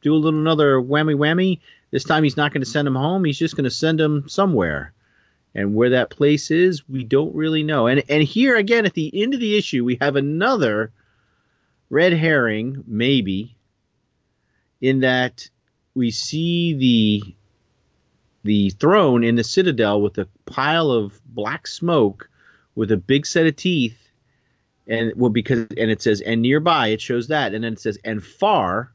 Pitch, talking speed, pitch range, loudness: 130 Hz, 180 wpm, 110-155 Hz, -19 LUFS